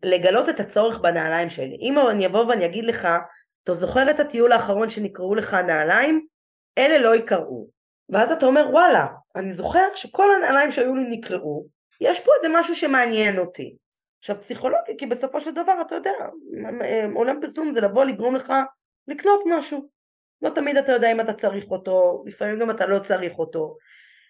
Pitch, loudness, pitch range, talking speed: 240 Hz, -21 LUFS, 195-290 Hz, 170 wpm